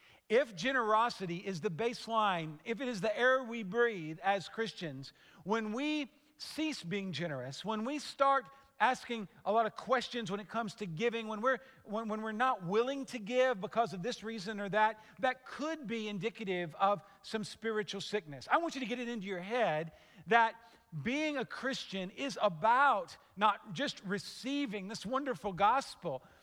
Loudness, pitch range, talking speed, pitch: -35 LUFS, 200-250 Hz, 175 wpm, 220 Hz